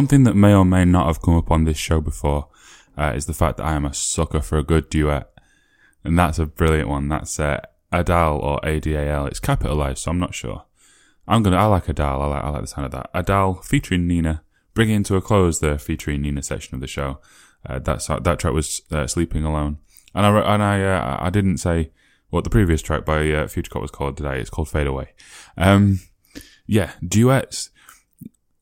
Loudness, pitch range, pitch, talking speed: -20 LUFS, 75-95 Hz, 80 Hz, 220 wpm